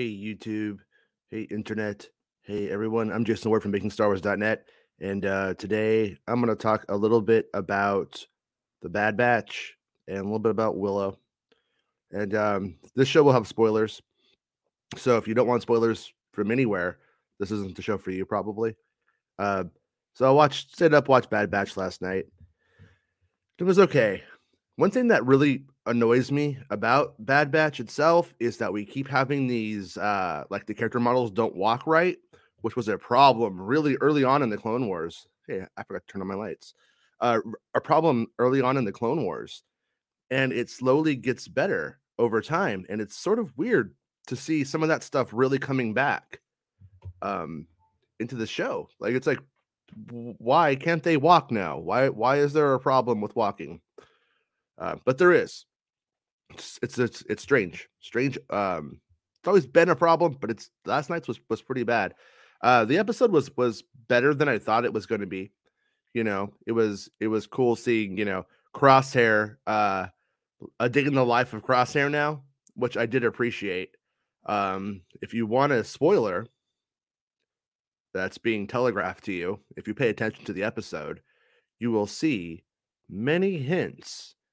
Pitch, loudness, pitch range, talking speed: 115 Hz, -25 LUFS, 105-135 Hz, 175 wpm